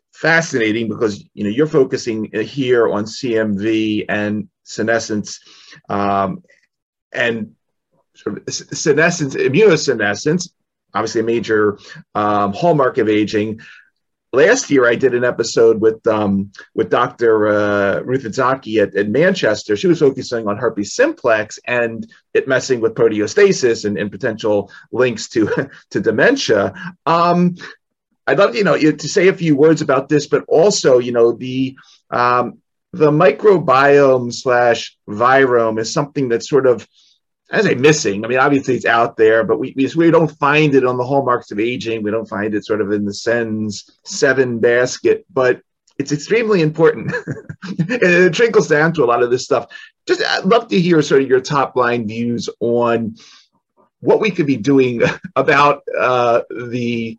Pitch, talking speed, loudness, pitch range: 125 Hz, 155 wpm, -15 LUFS, 110-155 Hz